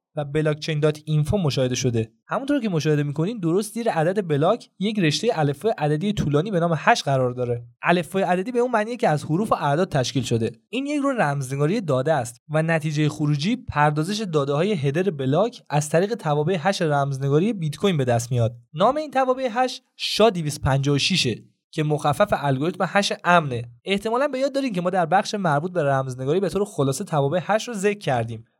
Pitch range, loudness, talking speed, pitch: 145-205 Hz, -22 LUFS, 185 wpm, 160 Hz